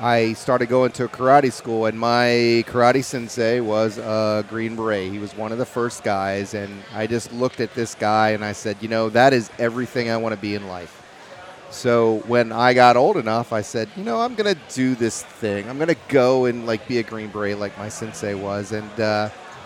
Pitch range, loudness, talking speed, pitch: 110-125 Hz, -21 LUFS, 230 wpm, 115 Hz